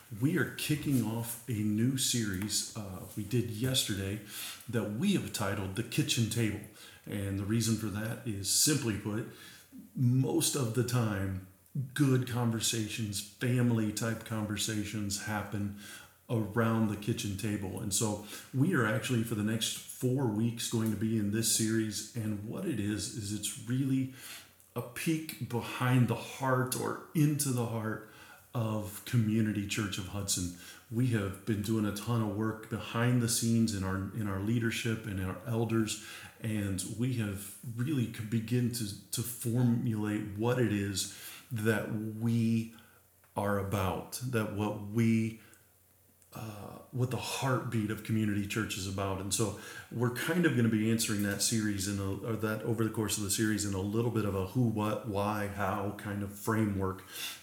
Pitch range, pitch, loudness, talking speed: 105-120 Hz, 110 Hz, -33 LUFS, 165 wpm